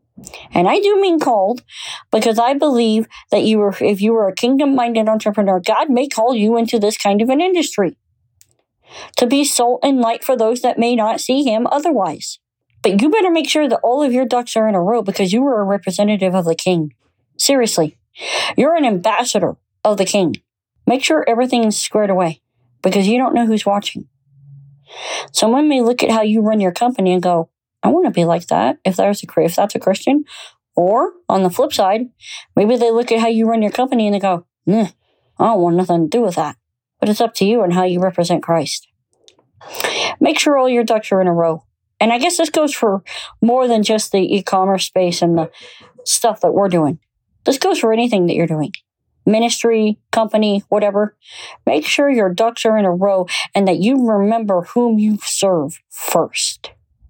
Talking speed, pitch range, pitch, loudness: 205 wpm, 185-240 Hz, 215 Hz, -16 LUFS